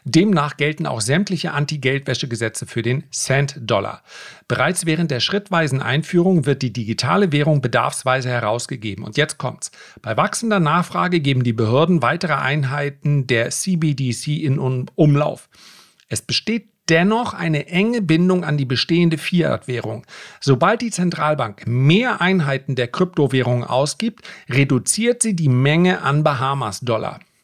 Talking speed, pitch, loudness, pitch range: 125 wpm, 145 Hz, -19 LUFS, 130-175 Hz